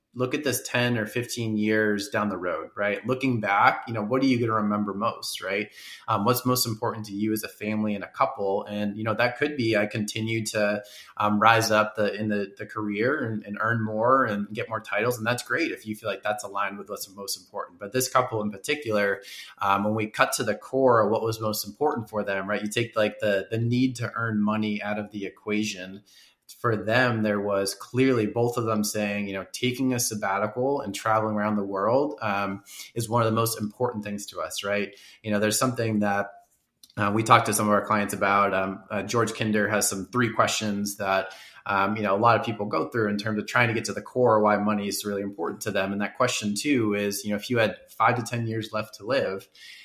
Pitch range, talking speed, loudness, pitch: 100-115 Hz, 240 wpm, -26 LUFS, 105 Hz